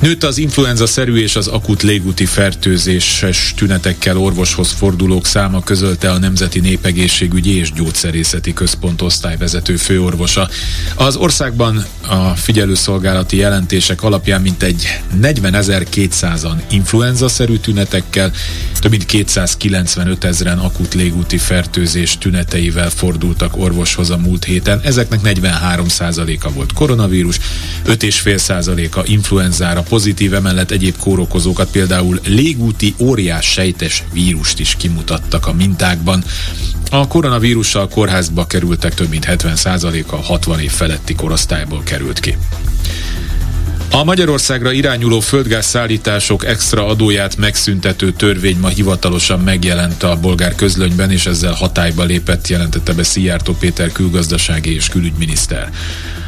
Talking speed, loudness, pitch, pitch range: 110 wpm, -13 LUFS, 90 Hz, 85-100 Hz